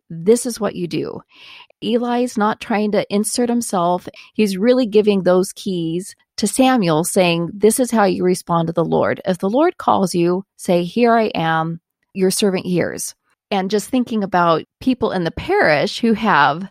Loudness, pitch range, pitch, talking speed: -17 LUFS, 175-230 Hz, 200 Hz, 175 wpm